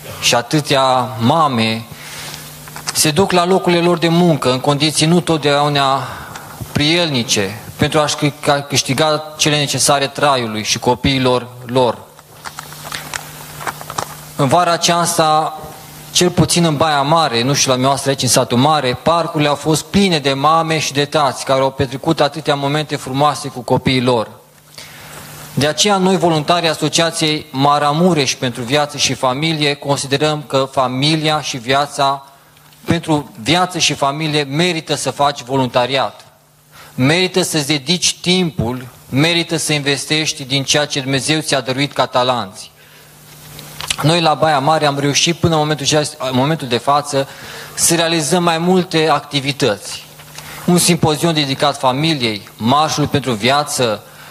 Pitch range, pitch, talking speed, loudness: 135-160 Hz, 145 Hz, 130 wpm, -15 LUFS